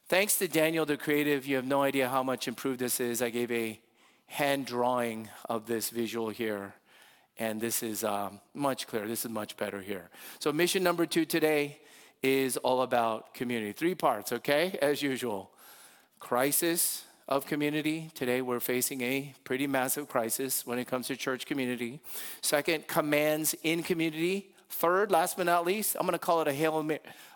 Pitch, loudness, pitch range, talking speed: 135 Hz, -30 LUFS, 120-160 Hz, 175 wpm